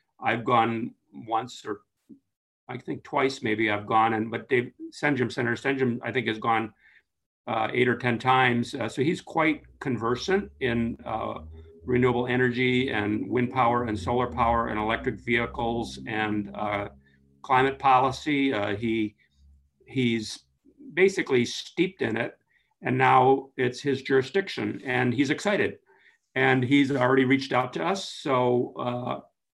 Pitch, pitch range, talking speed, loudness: 125 Hz, 110-135 Hz, 140 wpm, -26 LUFS